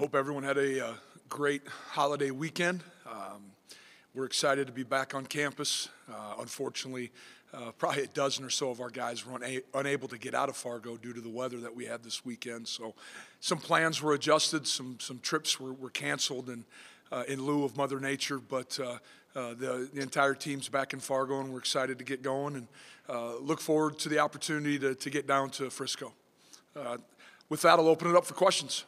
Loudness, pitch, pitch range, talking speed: -32 LUFS, 135 Hz, 125-145 Hz, 210 wpm